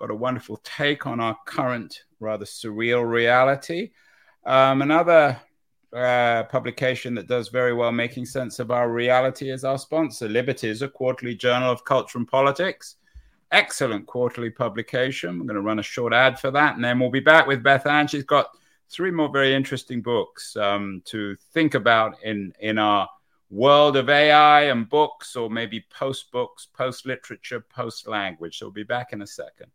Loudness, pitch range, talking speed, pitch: -21 LUFS, 115-140 Hz, 180 wpm, 125 Hz